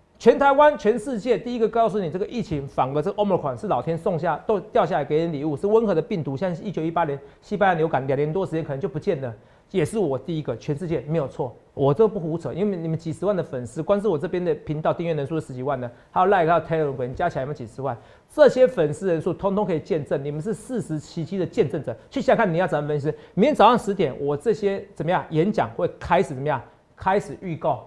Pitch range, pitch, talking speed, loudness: 150-205 Hz, 165 Hz, 410 characters per minute, -23 LUFS